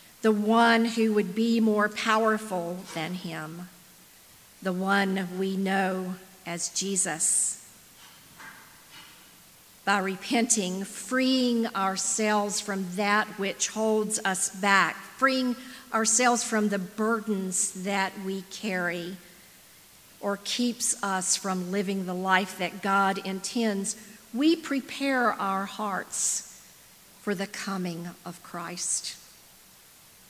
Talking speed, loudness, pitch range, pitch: 105 wpm, -27 LUFS, 190-220 Hz, 195 Hz